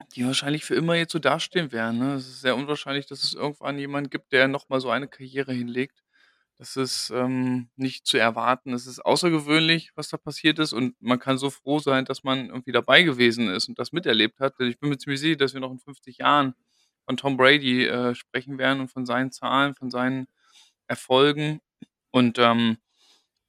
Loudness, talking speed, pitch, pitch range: -24 LUFS, 200 wpm, 130 Hz, 125-140 Hz